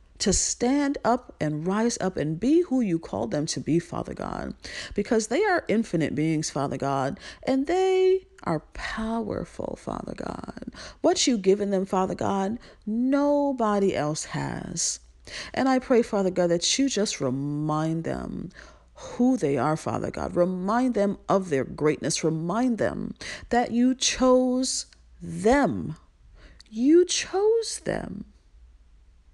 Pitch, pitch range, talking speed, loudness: 205 Hz, 155-255 Hz, 135 wpm, -25 LUFS